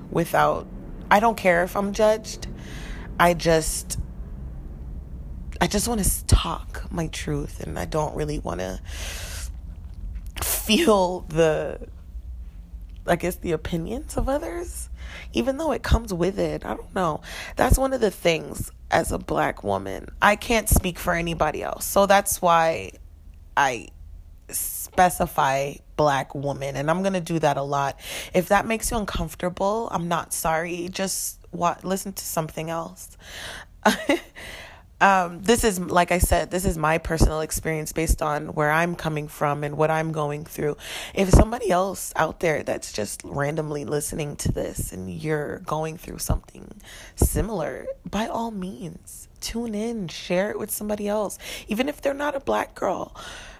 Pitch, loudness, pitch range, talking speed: 160 Hz, -24 LUFS, 120-190 Hz, 155 wpm